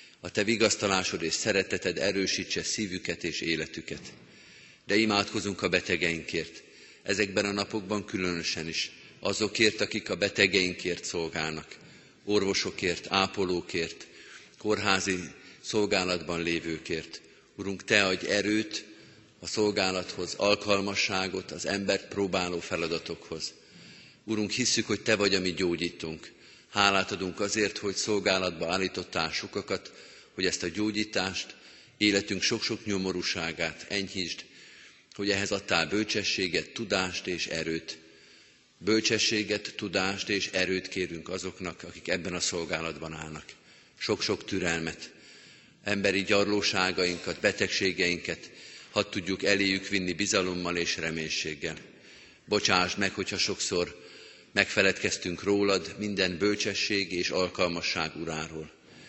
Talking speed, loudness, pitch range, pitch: 105 wpm, -29 LUFS, 85-105 Hz, 95 Hz